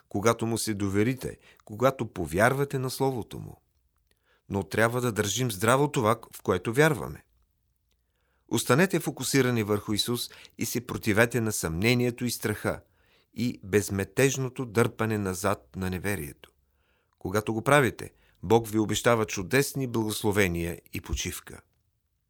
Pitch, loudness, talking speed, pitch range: 110 Hz, -27 LUFS, 120 wpm, 100-125 Hz